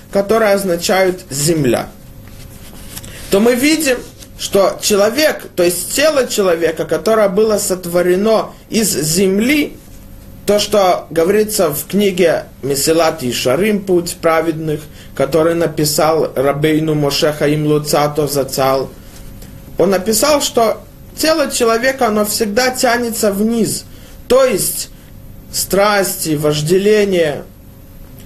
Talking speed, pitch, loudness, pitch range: 100 wpm, 180 Hz, -14 LUFS, 150-215 Hz